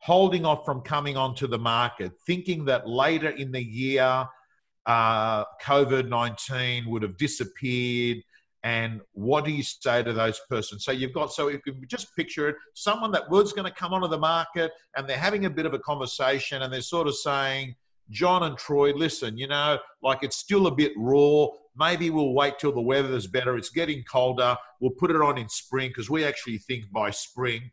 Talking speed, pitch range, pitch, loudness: 200 wpm, 125-155 Hz, 135 Hz, -26 LUFS